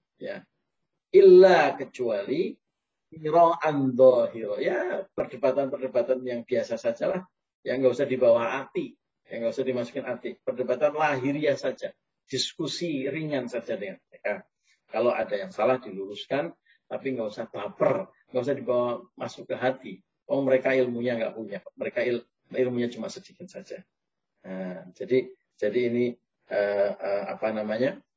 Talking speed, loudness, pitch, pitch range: 135 wpm, -26 LUFS, 130 Hz, 120-180 Hz